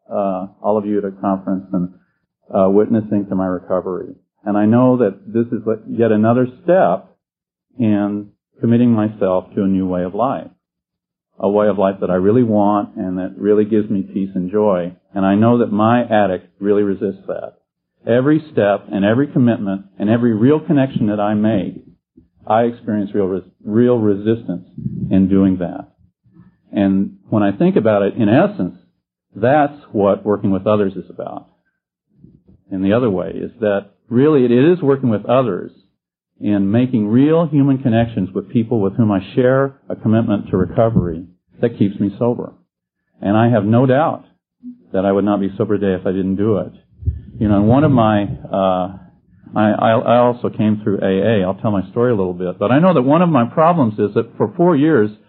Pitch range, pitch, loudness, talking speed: 95-120 Hz, 105 Hz, -16 LUFS, 185 wpm